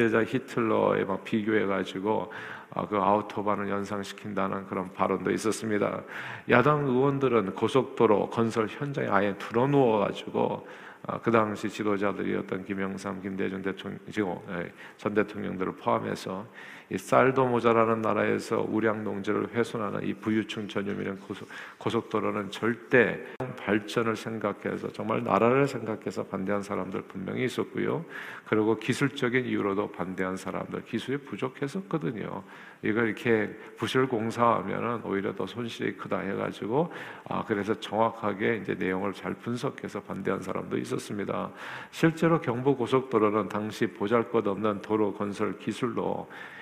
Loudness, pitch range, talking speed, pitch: -29 LUFS, 100-115 Hz, 325 characters per minute, 105 Hz